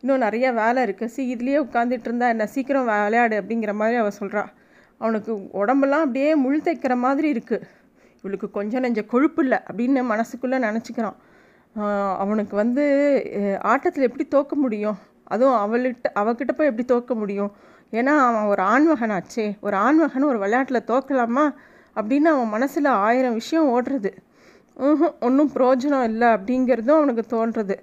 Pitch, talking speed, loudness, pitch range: 245 Hz, 140 wpm, -21 LUFS, 215-275 Hz